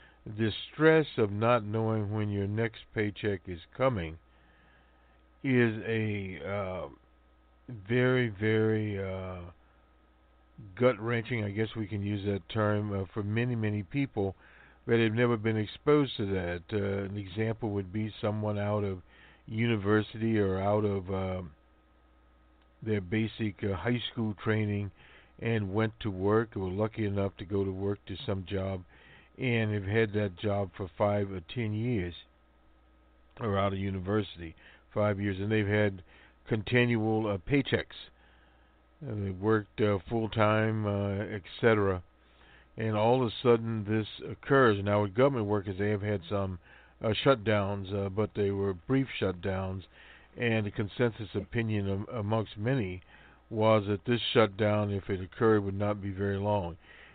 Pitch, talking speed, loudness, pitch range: 105 Hz, 150 wpm, -31 LUFS, 95-110 Hz